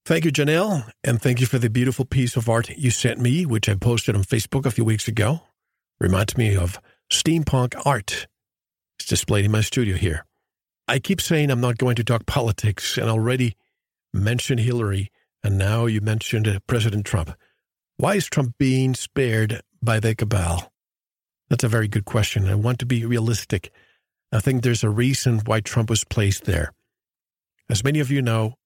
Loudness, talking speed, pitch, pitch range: -22 LUFS, 180 wpm, 115 Hz, 110-130 Hz